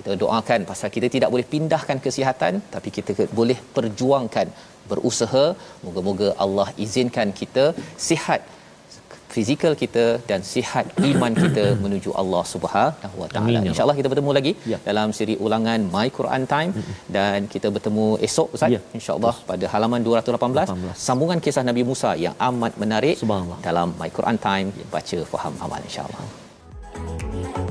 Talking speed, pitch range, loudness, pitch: 135 wpm, 100-130 Hz, -22 LUFS, 115 Hz